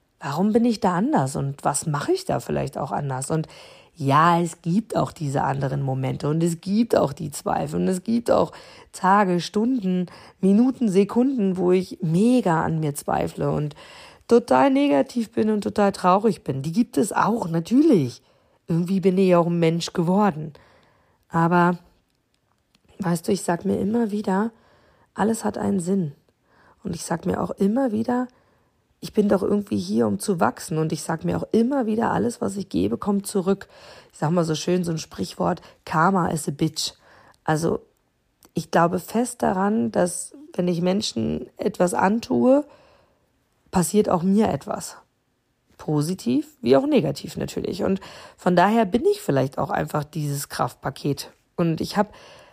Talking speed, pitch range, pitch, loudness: 165 wpm, 165-220 Hz, 190 Hz, -23 LUFS